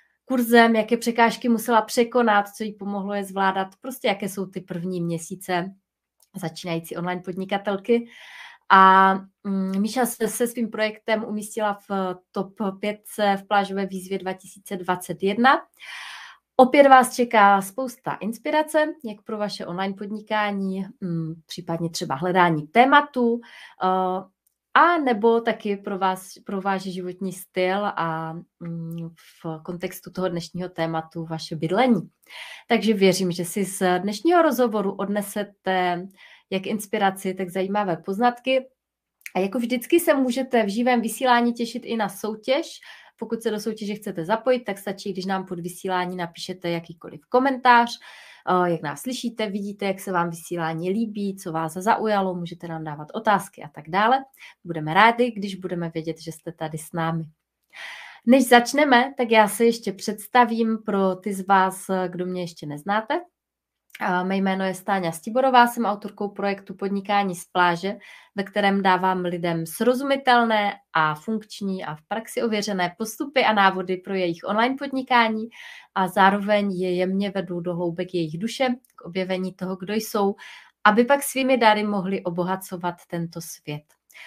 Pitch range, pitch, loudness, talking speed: 180-230 Hz, 200 Hz, -23 LUFS, 140 wpm